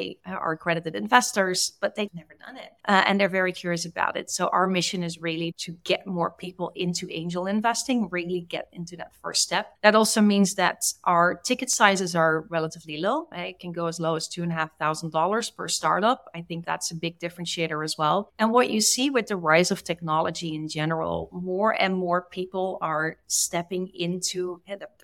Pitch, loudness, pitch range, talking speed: 180 Hz, -25 LUFS, 165-195 Hz, 190 wpm